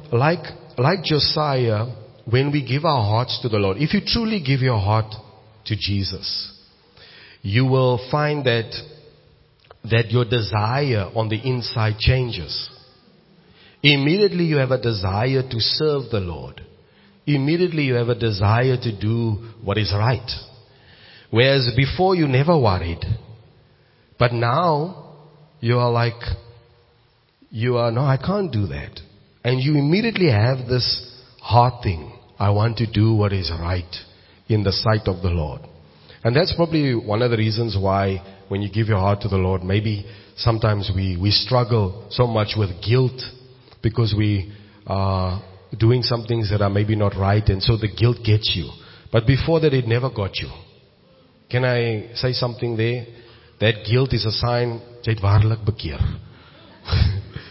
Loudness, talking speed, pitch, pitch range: -20 LUFS, 150 wpm, 115 Hz, 105-130 Hz